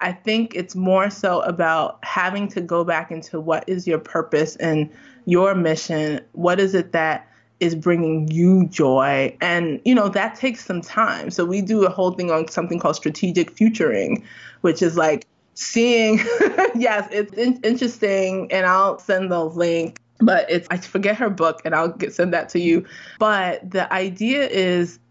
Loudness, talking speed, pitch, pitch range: -20 LUFS, 175 wpm, 180 Hz, 165-200 Hz